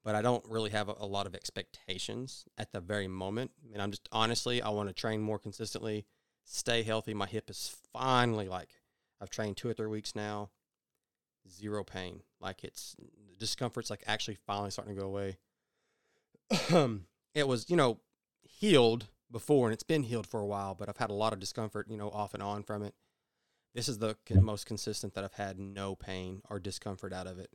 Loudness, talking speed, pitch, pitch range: -35 LUFS, 205 wpm, 105 Hz, 100-115 Hz